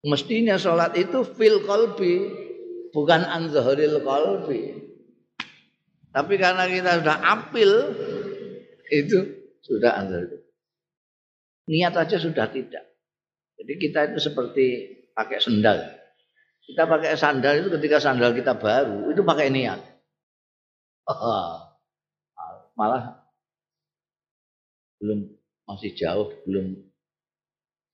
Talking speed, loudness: 90 wpm, -22 LUFS